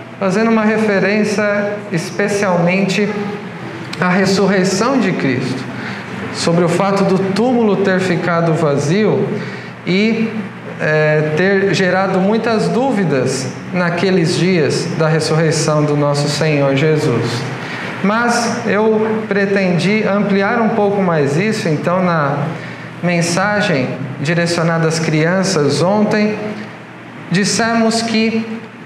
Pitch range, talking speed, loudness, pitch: 165-210 Hz, 100 wpm, -15 LUFS, 190 Hz